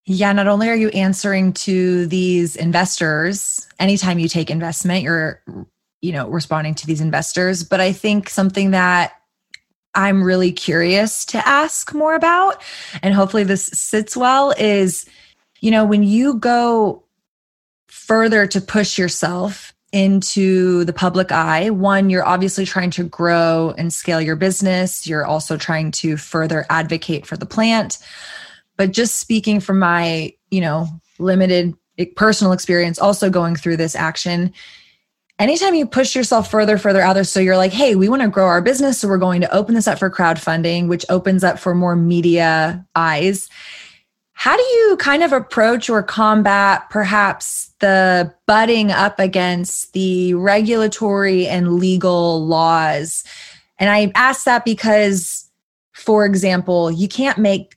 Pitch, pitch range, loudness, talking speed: 190 Hz, 175-210 Hz, -16 LUFS, 155 wpm